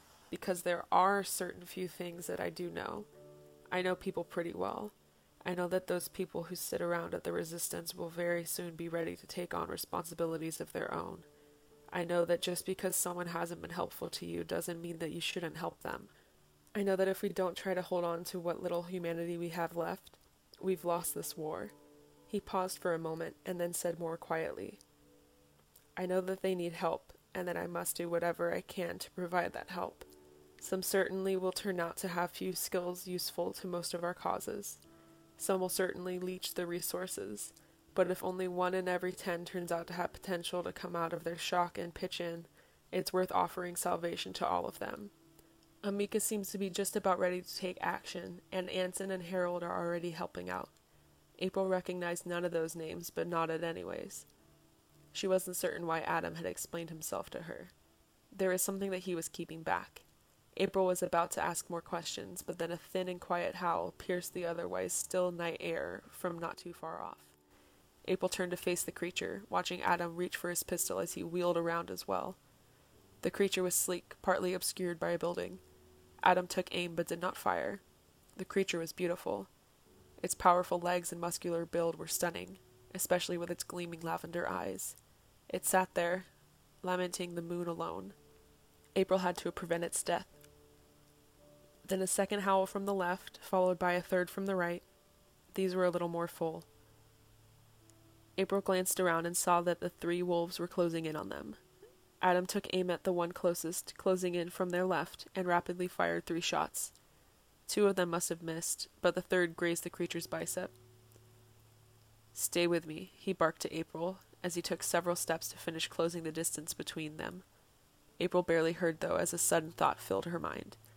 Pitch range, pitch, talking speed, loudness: 165-180 Hz, 175 Hz, 190 wpm, -36 LUFS